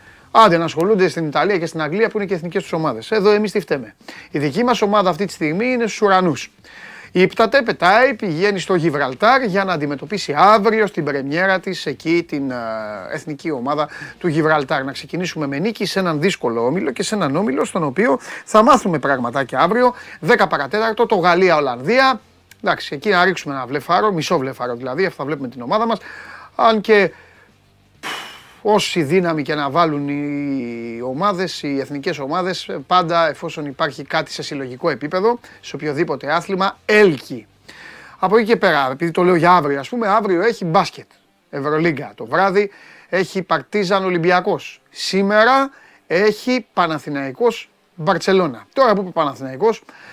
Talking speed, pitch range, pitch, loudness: 165 wpm, 150-210 Hz, 180 Hz, -18 LUFS